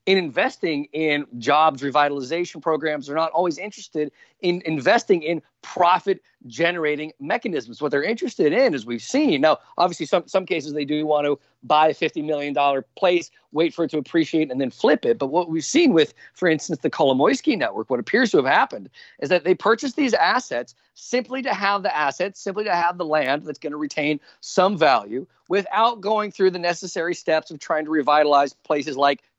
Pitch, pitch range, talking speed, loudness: 160 Hz, 150-185 Hz, 195 wpm, -21 LUFS